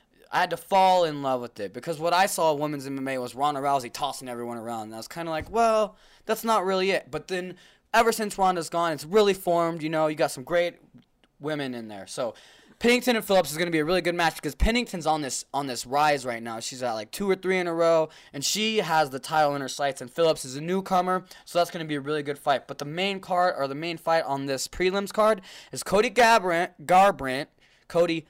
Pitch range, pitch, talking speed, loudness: 140-185 Hz, 165 Hz, 250 wpm, -25 LUFS